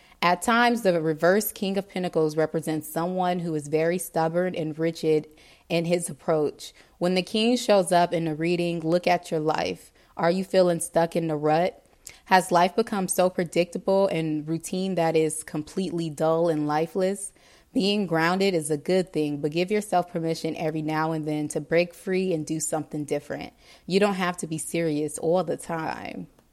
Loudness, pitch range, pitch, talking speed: -25 LUFS, 160-185 Hz, 170 Hz, 180 wpm